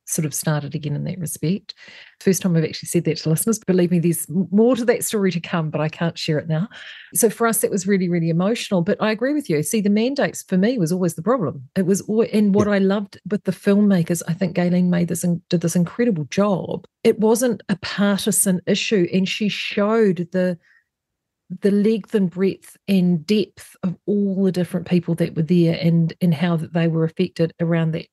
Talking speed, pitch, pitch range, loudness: 220 wpm, 185 Hz, 170-205 Hz, -20 LUFS